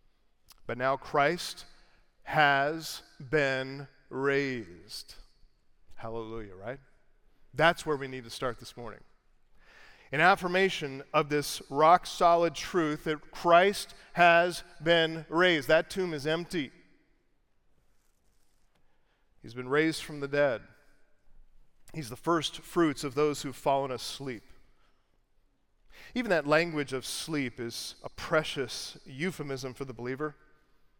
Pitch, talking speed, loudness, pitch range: 150 Hz, 115 wpm, -29 LUFS, 130-165 Hz